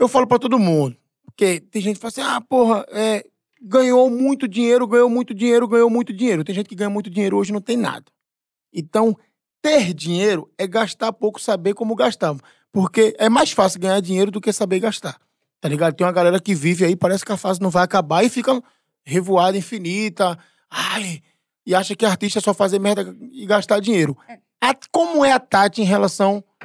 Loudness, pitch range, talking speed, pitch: -18 LUFS, 190-235 Hz, 205 wpm, 210 Hz